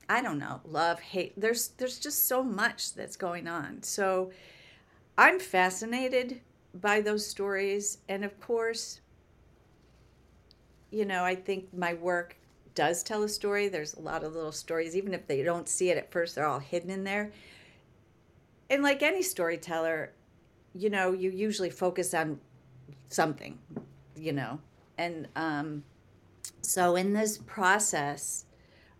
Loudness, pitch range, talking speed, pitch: -30 LUFS, 160-205 Hz, 145 wpm, 180 Hz